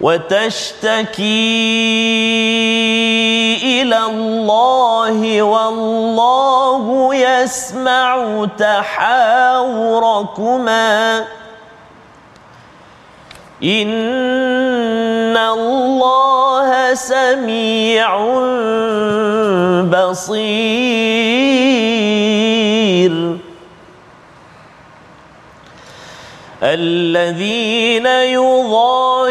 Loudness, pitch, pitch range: -13 LUFS, 225 Hz, 215-255 Hz